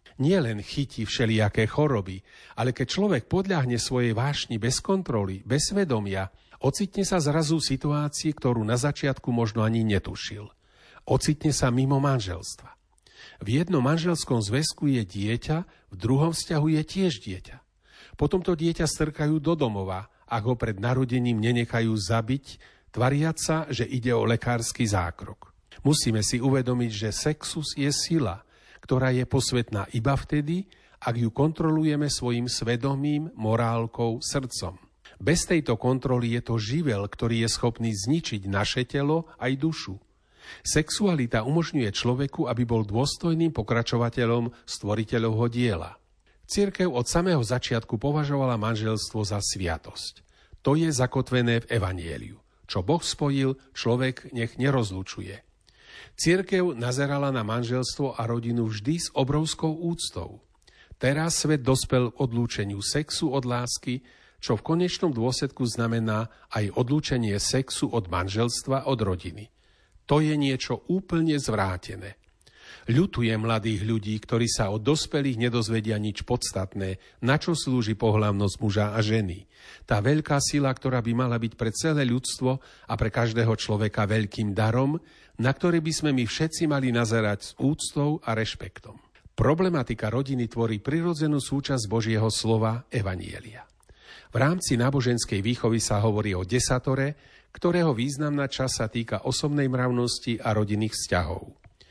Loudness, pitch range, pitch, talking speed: -26 LUFS, 110-145 Hz, 125 Hz, 135 wpm